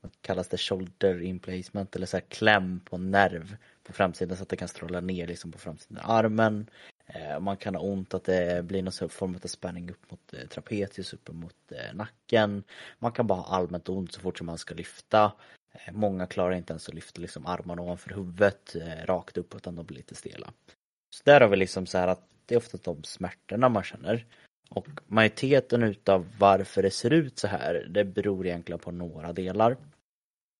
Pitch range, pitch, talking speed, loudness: 90-105 Hz, 95 Hz, 195 wpm, -28 LUFS